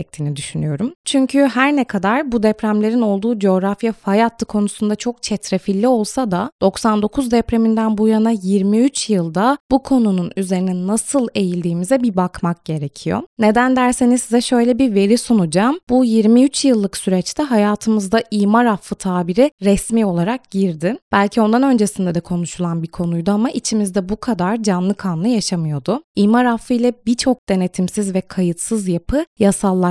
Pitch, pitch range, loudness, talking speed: 215 Hz, 190-240 Hz, -17 LUFS, 140 wpm